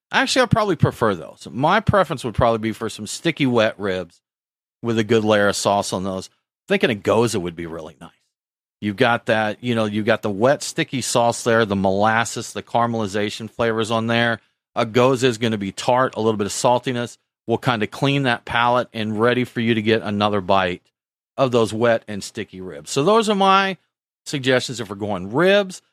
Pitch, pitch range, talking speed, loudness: 115 Hz, 105-125 Hz, 210 wpm, -20 LUFS